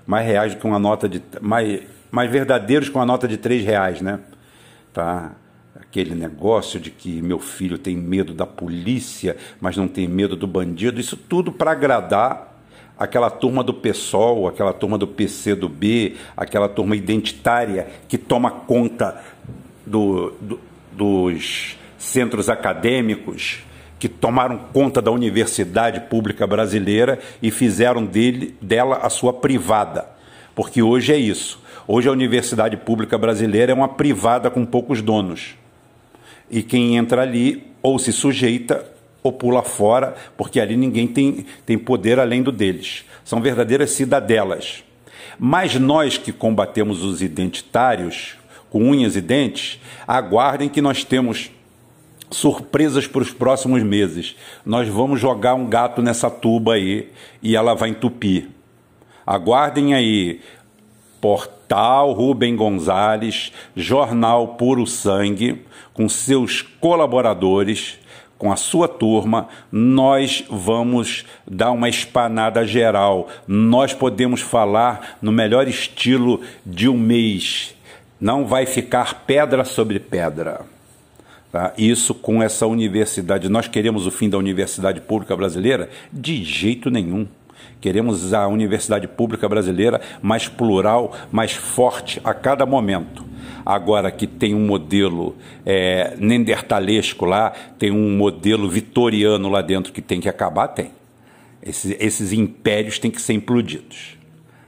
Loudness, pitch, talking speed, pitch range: -19 LUFS, 115 Hz, 130 wpm, 105-125 Hz